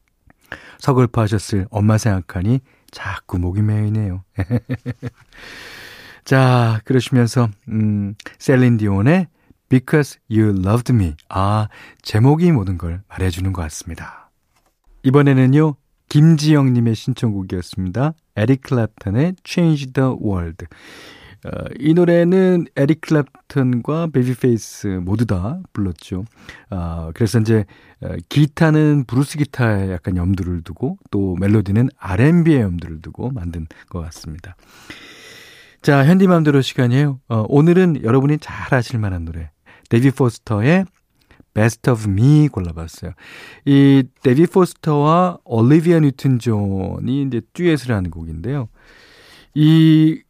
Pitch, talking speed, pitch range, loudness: 120 Hz, 285 characters per minute, 100-145 Hz, -17 LUFS